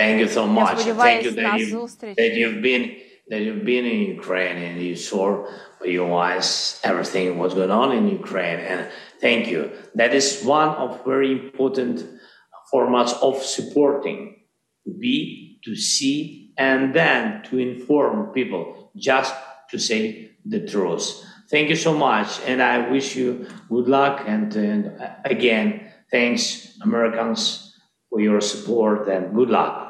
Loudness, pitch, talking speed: -21 LUFS, 135 Hz, 150 wpm